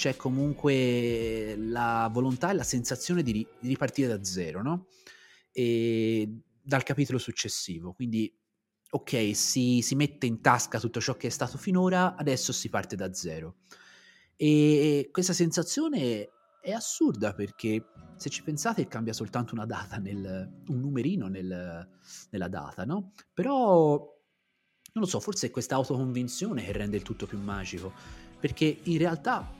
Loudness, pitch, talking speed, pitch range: -29 LUFS, 125 Hz, 145 wpm, 110-150 Hz